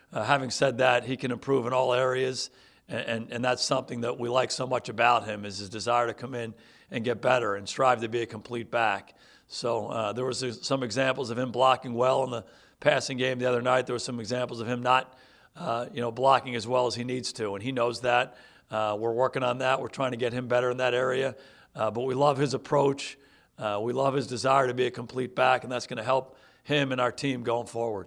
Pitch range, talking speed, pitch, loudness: 120-130 Hz, 250 wpm, 125 Hz, -28 LUFS